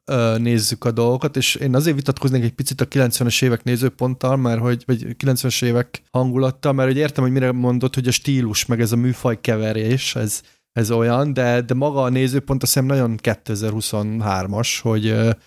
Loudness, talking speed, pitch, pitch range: -19 LUFS, 180 wpm, 125 Hz, 115-130 Hz